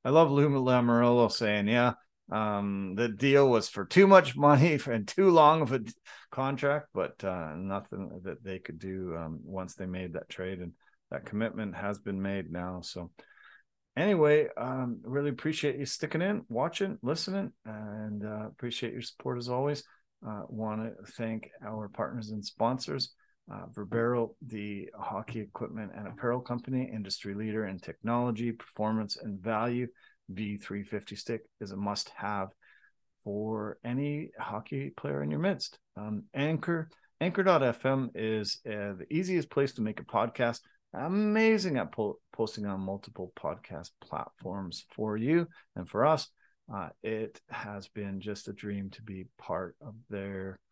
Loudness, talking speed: -31 LUFS, 155 wpm